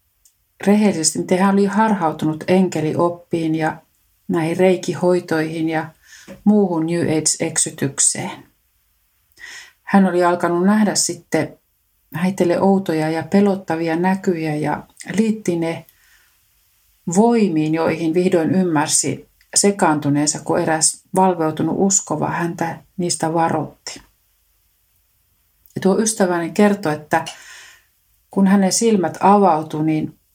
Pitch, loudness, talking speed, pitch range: 165 Hz, -18 LUFS, 90 wpm, 155-190 Hz